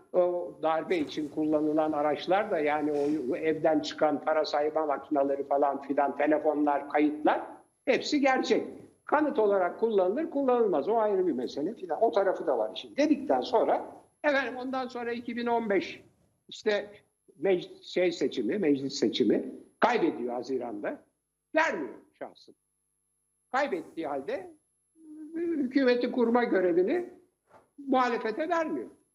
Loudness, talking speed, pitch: -29 LUFS, 115 wpm, 205 Hz